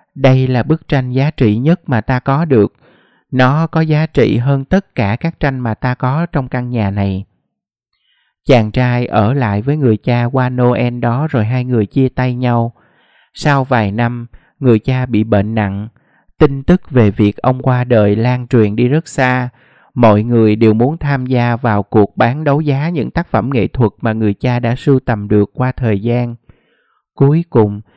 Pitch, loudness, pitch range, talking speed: 125 Hz, -14 LUFS, 110-135 Hz, 195 wpm